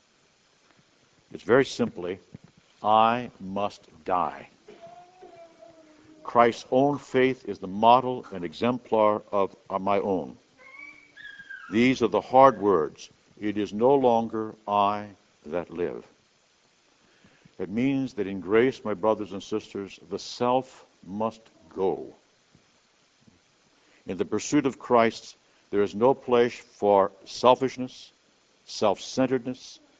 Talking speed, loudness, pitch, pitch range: 110 wpm, -25 LUFS, 120 Hz, 105-135 Hz